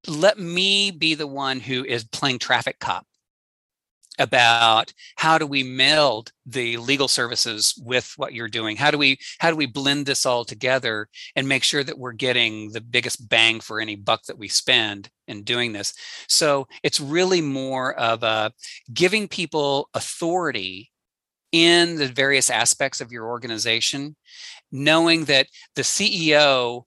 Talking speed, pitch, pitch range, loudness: 155 wpm, 135 Hz, 115-150 Hz, -20 LUFS